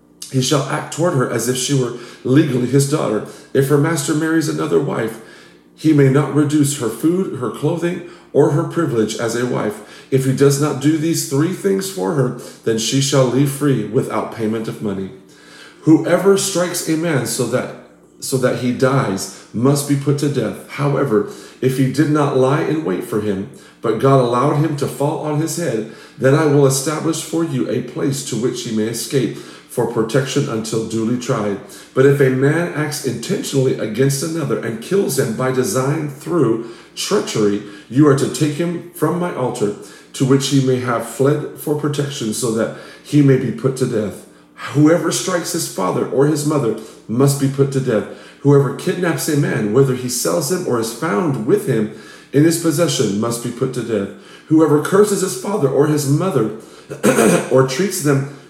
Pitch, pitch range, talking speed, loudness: 140 Hz, 125-155 Hz, 190 wpm, -17 LUFS